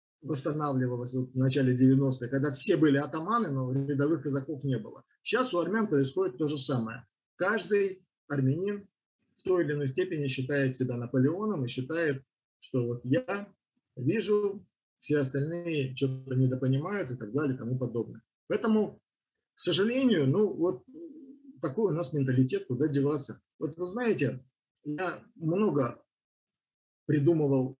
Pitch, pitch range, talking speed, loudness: 145 Hz, 130-185 Hz, 135 wpm, -29 LUFS